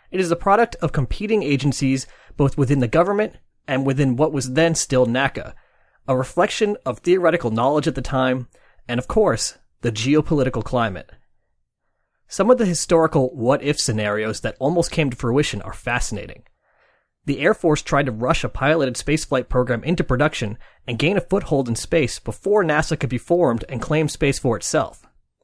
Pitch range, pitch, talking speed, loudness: 125-165 Hz, 140 Hz, 170 wpm, -20 LUFS